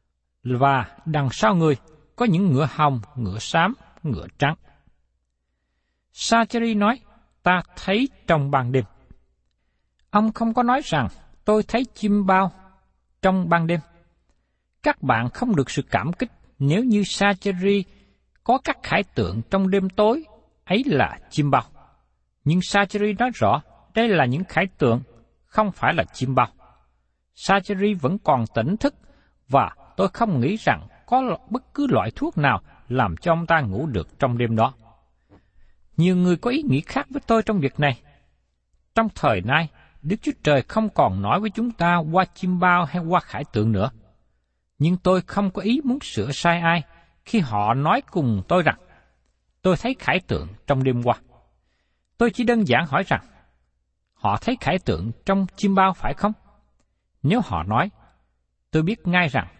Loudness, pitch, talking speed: -22 LUFS, 160 Hz, 165 wpm